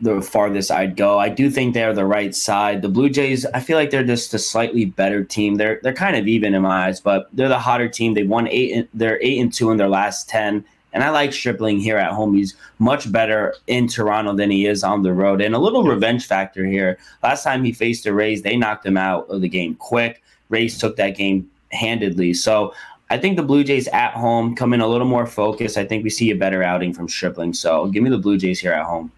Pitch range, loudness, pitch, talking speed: 100-120 Hz, -18 LUFS, 110 Hz, 255 wpm